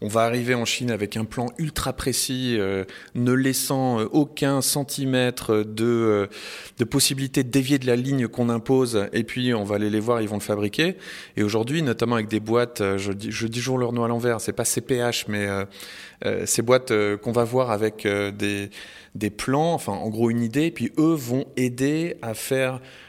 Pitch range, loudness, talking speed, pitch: 110-130 Hz, -23 LUFS, 210 wpm, 120 Hz